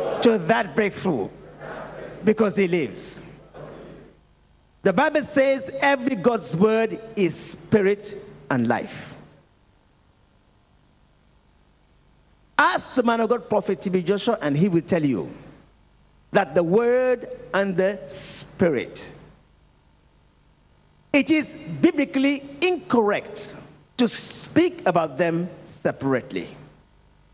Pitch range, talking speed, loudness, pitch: 160-240 Hz, 95 wpm, -22 LUFS, 195 Hz